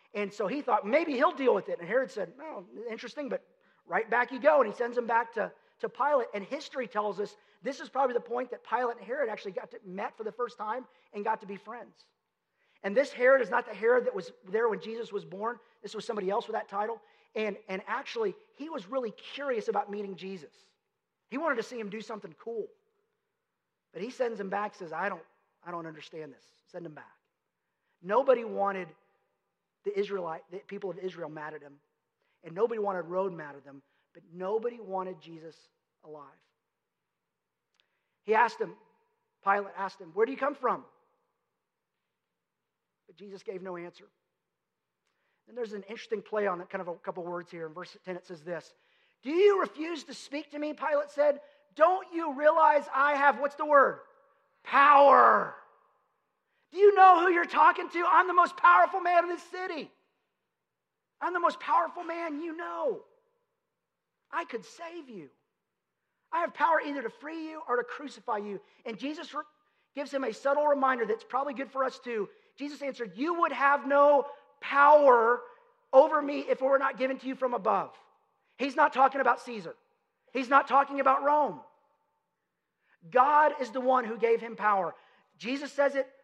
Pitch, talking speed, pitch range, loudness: 265 Hz, 190 wpm, 210-315 Hz, -28 LUFS